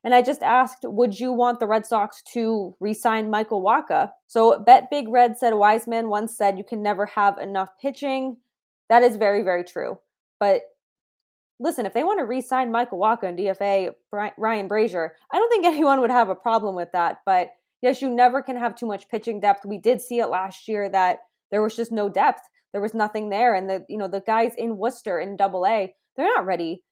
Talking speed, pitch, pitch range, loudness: 215 wpm, 220 Hz, 200-245 Hz, -22 LUFS